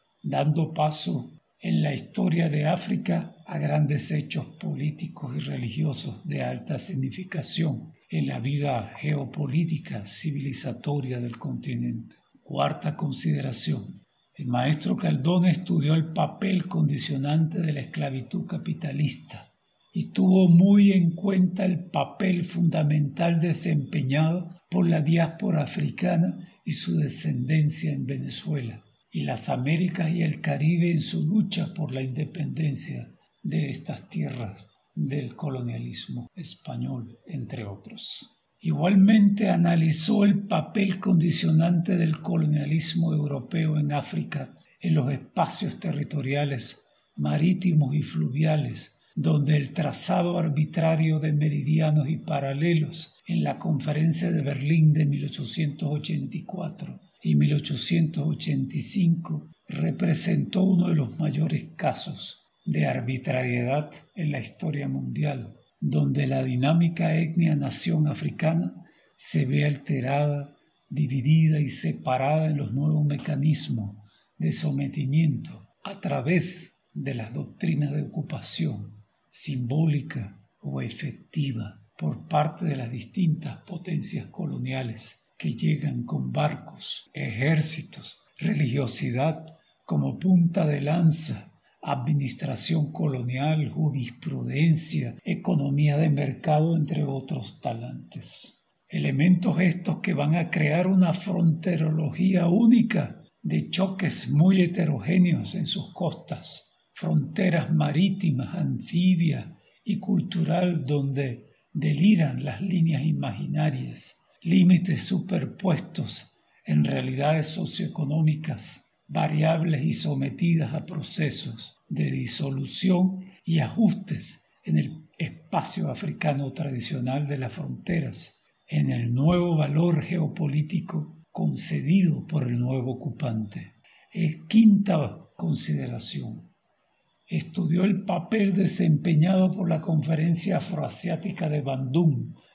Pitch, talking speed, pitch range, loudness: 155 Hz, 105 wpm, 145-175 Hz, -25 LUFS